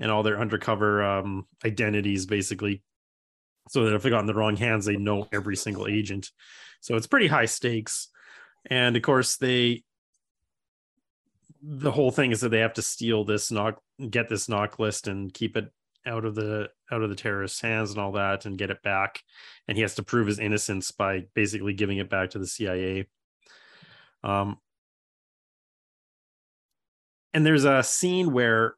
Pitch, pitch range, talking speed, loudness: 105 Hz, 100-115 Hz, 175 wpm, -26 LUFS